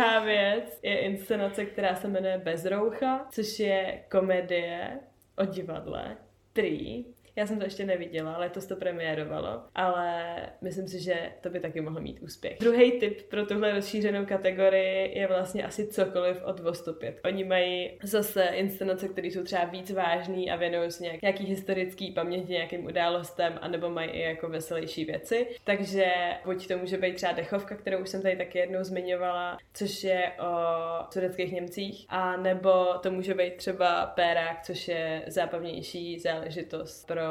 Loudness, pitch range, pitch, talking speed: -30 LUFS, 175-195 Hz, 185 Hz, 160 wpm